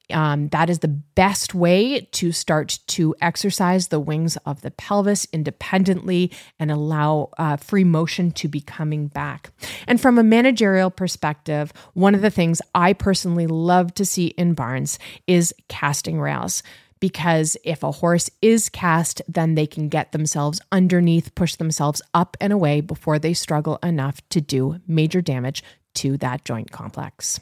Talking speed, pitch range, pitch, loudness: 160 wpm, 150-180 Hz, 165 Hz, -20 LUFS